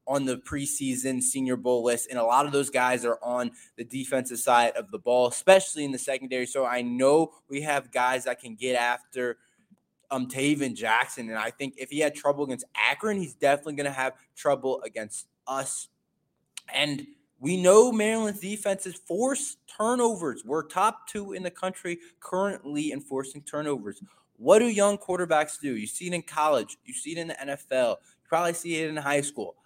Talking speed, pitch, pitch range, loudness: 190 wpm, 145 Hz, 130-180 Hz, -27 LUFS